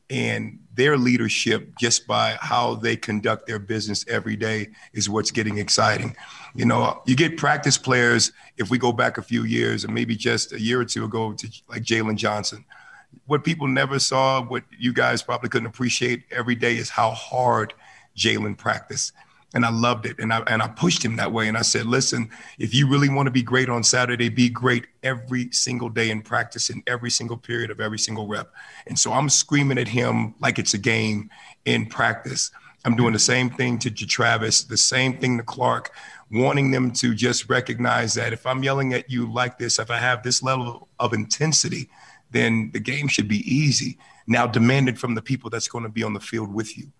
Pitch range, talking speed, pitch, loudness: 115-125 Hz, 210 wpm, 120 Hz, -22 LUFS